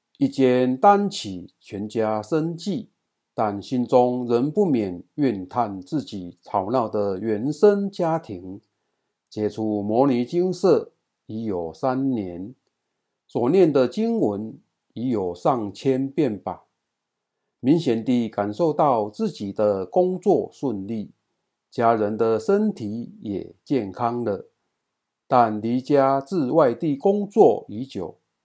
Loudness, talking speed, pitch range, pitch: -22 LUFS, 165 characters per minute, 105-160 Hz, 120 Hz